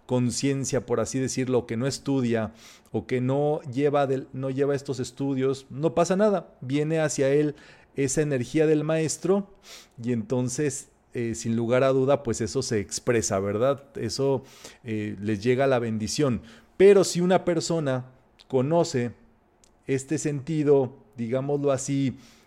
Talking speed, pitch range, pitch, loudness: 145 wpm, 120-150 Hz, 135 Hz, -25 LUFS